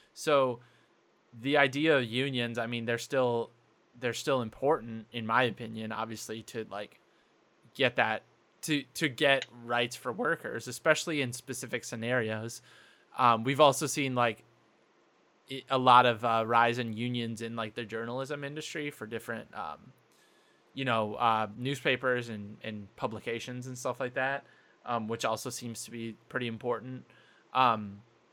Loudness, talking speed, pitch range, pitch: -31 LUFS, 150 wpm, 115-130 Hz, 120 Hz